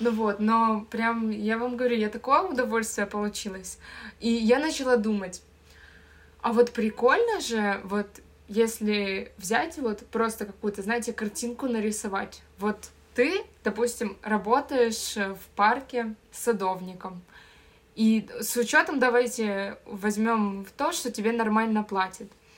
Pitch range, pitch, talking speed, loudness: 205-240 Hz, 225 Hz, 125 wpm, -27 LUFS